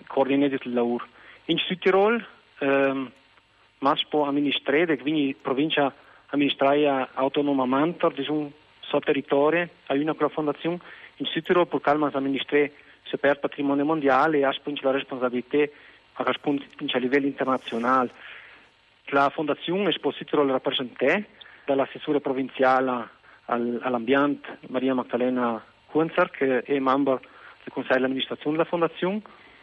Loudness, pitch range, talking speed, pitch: -25 LUFS, 130-150 Hz, 125 wpm, 140 Hz